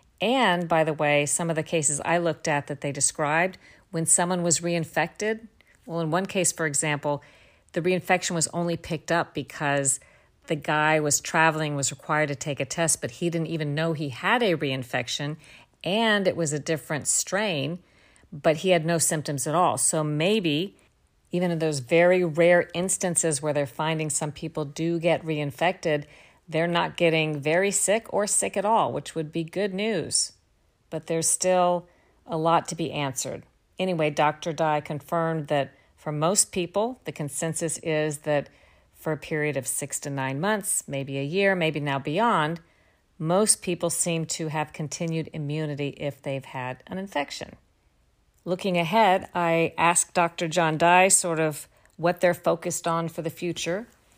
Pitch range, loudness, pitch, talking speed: 150-175 Hz, -25 LUFS, 165 Hz, 170 wpm